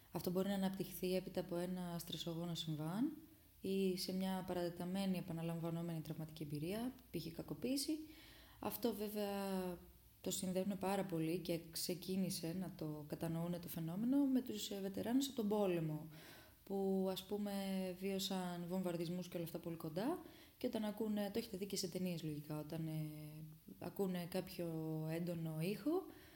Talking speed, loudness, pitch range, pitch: 145 wpm, -43 LUFS, 165-200 Hz, 185 Hz